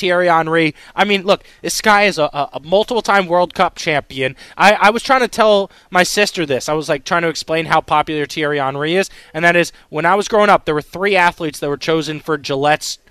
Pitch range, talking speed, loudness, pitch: 150-195 Hz, 240 wpm, -15 LUFS, 165 Hz